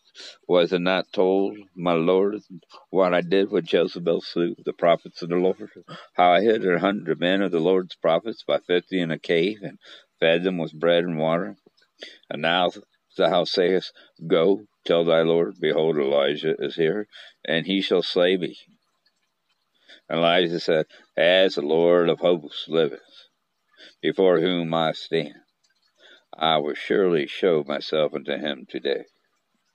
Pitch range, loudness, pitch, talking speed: 85-95 Hz, -22 LUFS, 90 Hz, 155 wpm